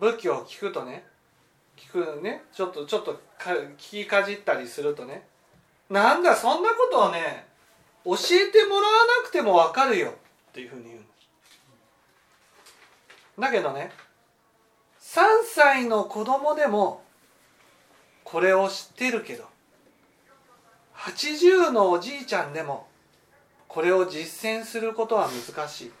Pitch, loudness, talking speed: 225 Hz, -23 LUFS, 240 characters per minute